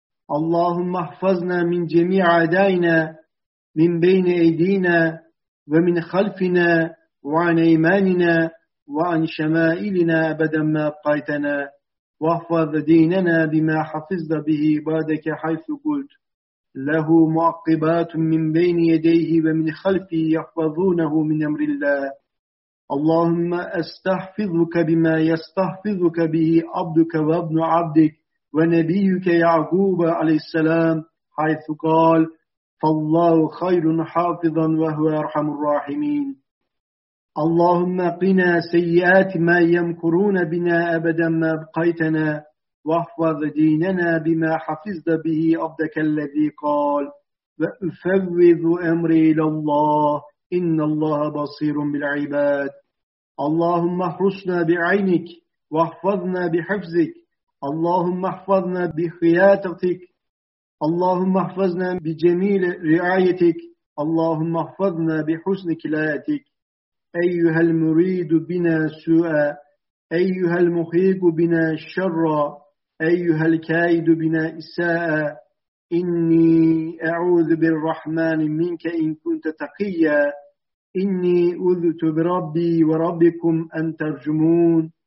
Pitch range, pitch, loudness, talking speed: 160-175 Hz, 165 Hz, -20 LUFS, 85 wpm